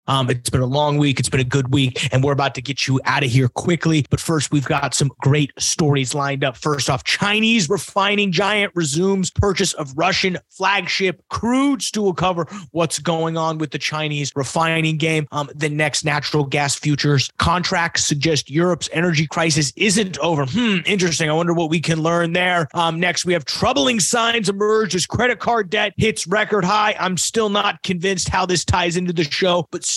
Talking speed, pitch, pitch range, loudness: 195 wpm, 165 Hz, 145-190 Hz, -18 LUFS